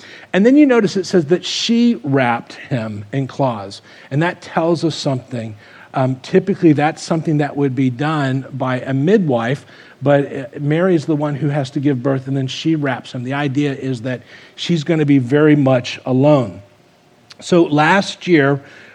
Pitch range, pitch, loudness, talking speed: 130-165 Hz, 145 Hz, -16 LUFS, 180 wpm